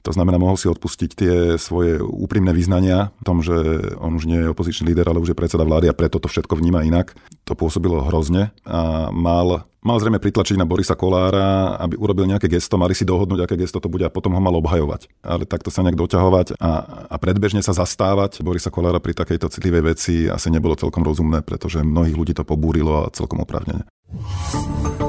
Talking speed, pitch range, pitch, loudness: 200 wpm, 80-95 Hz, 85 Hz, -19 LUFS